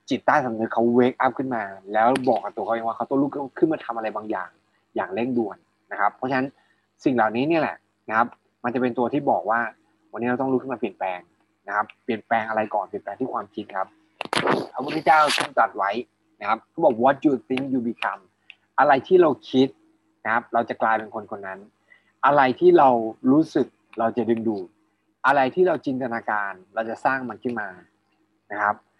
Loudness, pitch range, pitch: -23 LUFS, 110-135 Hz, 120 Hz